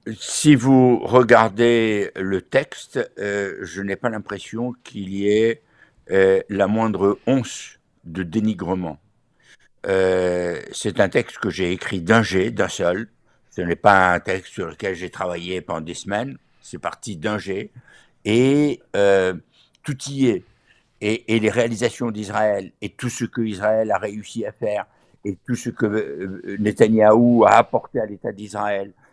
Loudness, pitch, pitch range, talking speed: -20 LUFS, 105 Hz, 95-115 Hz, 155 wpm